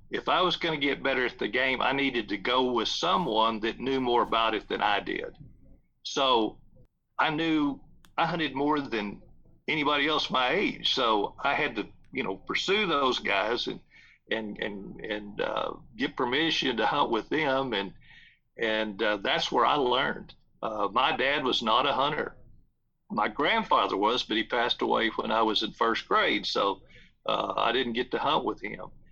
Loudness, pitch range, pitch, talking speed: -27 LUFS, 115-145 Hz, 130 Hz, 190 wpm